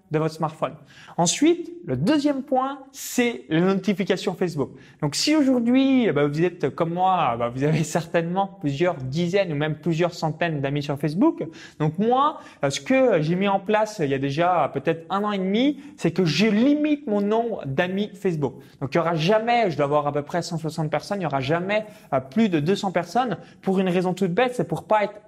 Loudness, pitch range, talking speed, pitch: -23 LUFS, 155-220 Hz, 205 wpm, 185 Hz